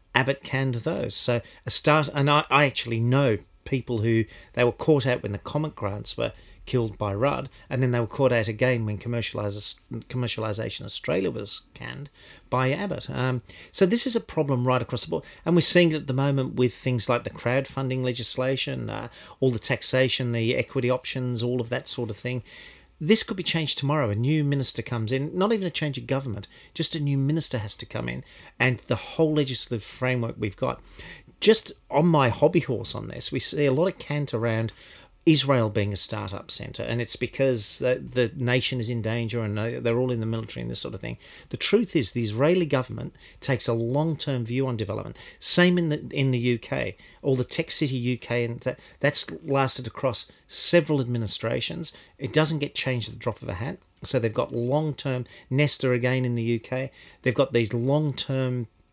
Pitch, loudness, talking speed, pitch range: 125 Hz, -25 LUFS, 205 wpm, 115-140 Hz